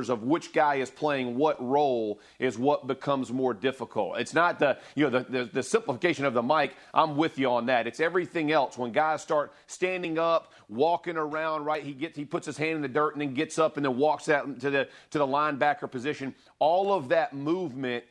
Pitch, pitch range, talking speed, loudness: 145 Hz, 130-160 Hz, 220 wpm, -28 LUFS